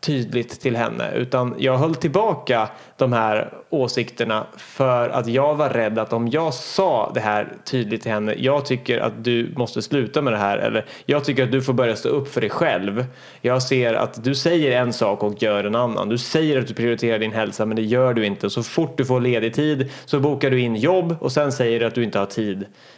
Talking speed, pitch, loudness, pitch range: 230 wpm, 125 Hz, -21 LUFS, 115-140 Hz